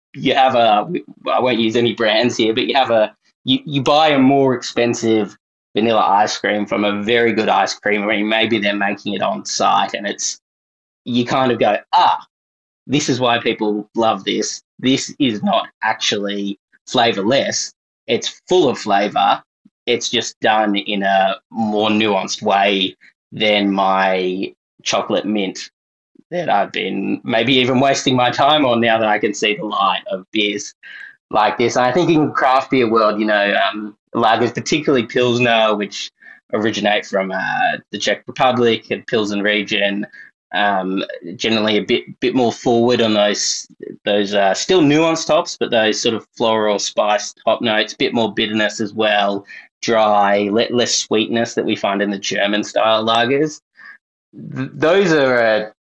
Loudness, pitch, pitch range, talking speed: -16 LUFS, 110 Hz, 105-120 Hz, 165 wpm